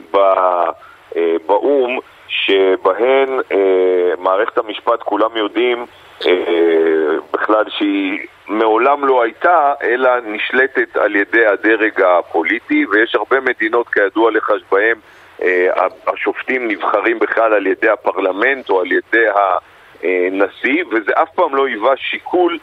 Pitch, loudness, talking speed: 300 Hz, -15 LUFS, 115 wpm